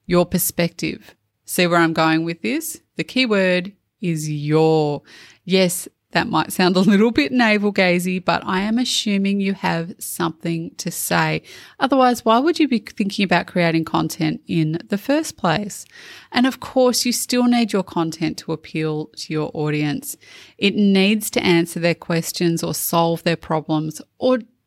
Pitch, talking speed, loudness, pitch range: 180 Hz, 160 wpm, -19 LUFS, 165-230 Hz